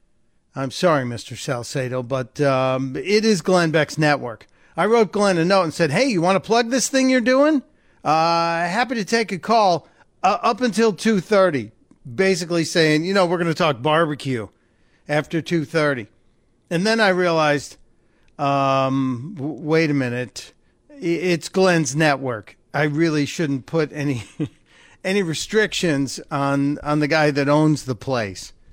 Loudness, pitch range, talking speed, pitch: -20 LUFS, 135-185 Hz, 160 wpm, 155 Hz